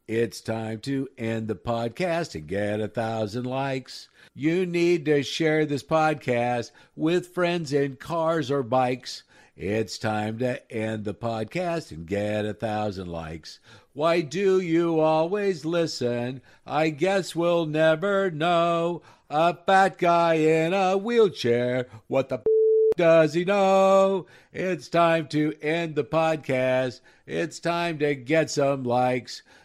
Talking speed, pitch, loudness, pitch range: 140 wpm, 155 Hz, -24 LUFS, 120-170 Hz